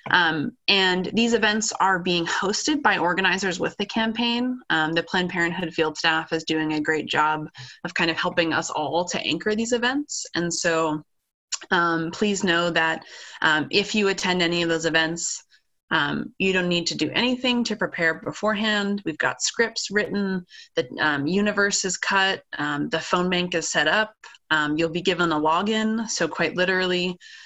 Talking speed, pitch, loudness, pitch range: 180 wpm, 180 Hz, -23 LUFS, 165-210 Hz